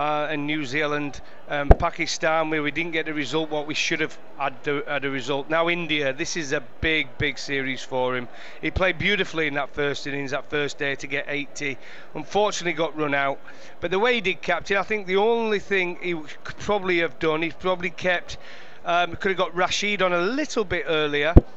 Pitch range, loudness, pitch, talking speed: 145-180 Hz, -24 LUFS, 160 Hz, 215 wpm